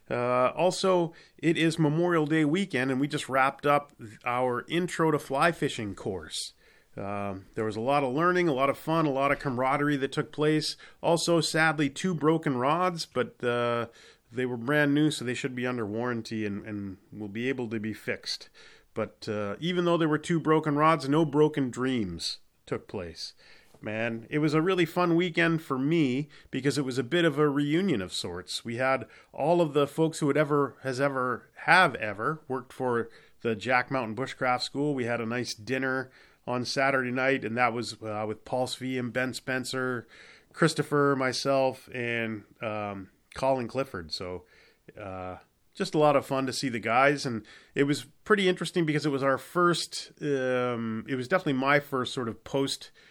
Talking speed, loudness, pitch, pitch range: 190 wpm, -28 LUFS, 135 Hz, 120-150 Hz